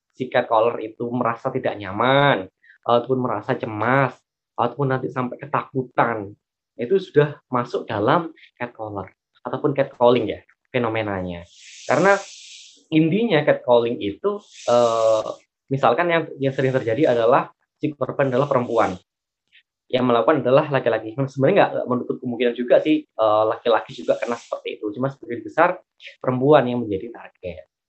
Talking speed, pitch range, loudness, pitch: 135 wpm, 115-140 Hz, -21 LUFS, 125 Hz